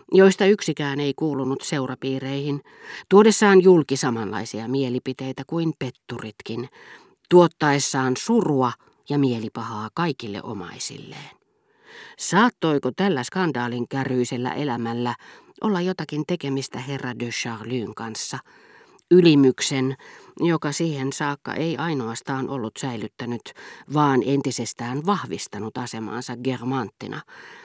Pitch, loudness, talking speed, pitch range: 135 Hz, -23 LUFS, 90 wpm, 125-160 Hz